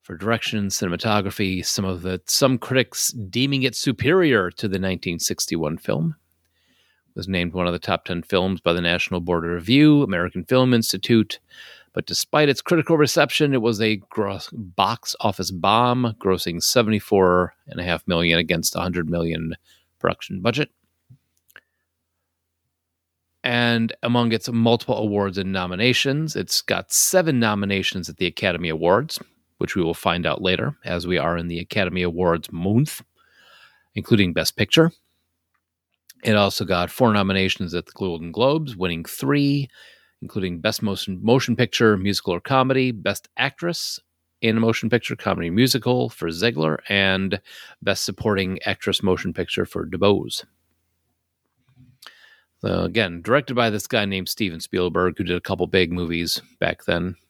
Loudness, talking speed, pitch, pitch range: -21 LUFS, 150 wpm, 100 Hz, 85-120 Hz